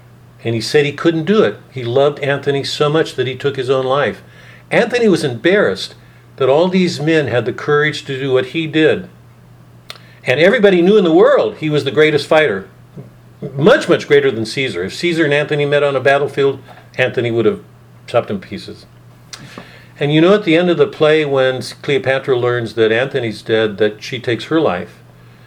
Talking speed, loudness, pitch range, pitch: 195 wpm, -14 LUFS, 120-155 Hz, 140 Hz